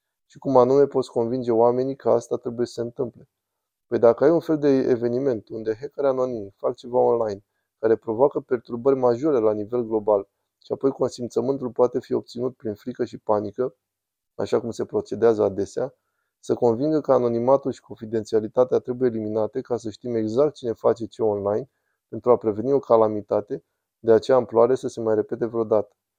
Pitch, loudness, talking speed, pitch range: 120 Hz, -23 LUFS, 175 wpm, 110-130 Hz